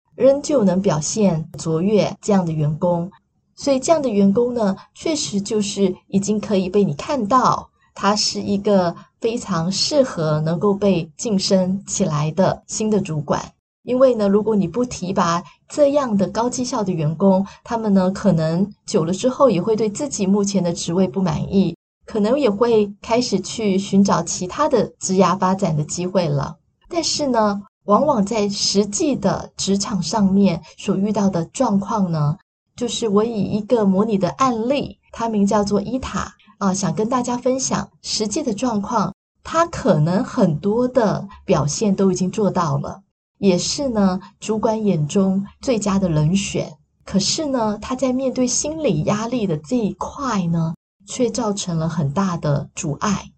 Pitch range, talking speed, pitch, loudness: 185-225 Hz, 240 characters per minute, 200 Hz, -19 LUFS